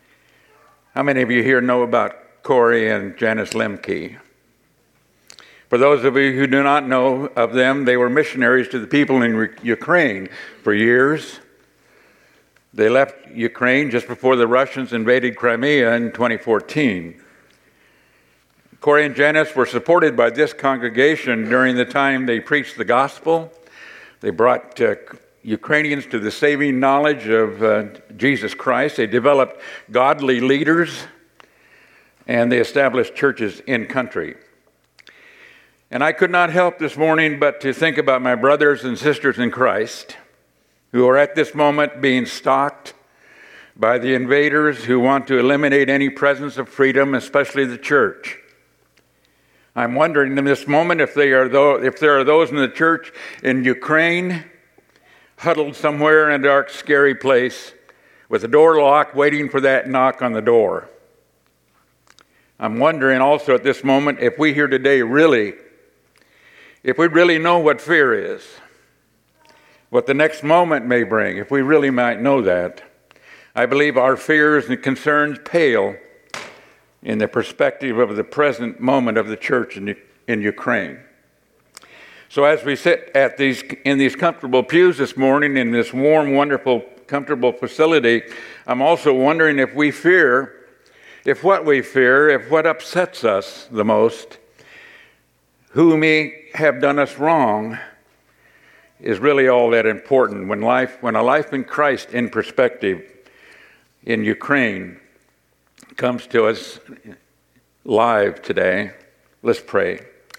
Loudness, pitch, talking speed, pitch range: -17 LUFS, 140 Hz, 145 wpm, 125-155 Hz